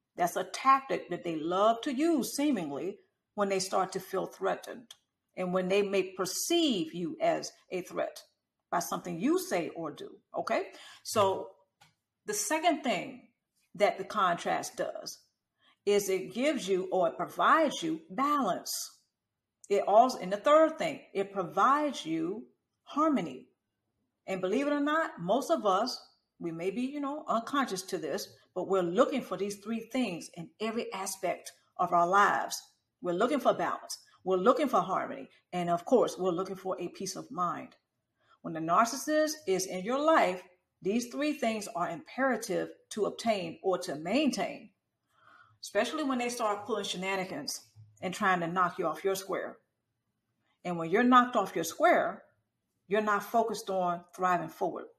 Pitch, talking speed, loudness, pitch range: 205 Hz, 165 wpm, -31 LUFS, 185-285 Hz